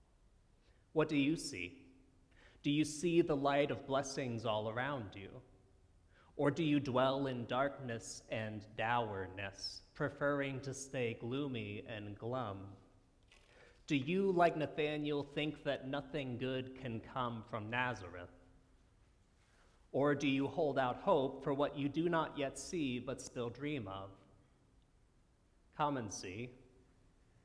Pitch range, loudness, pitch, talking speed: 105-145 Hz, -38 LUFS, 130 Hz, 130 wpm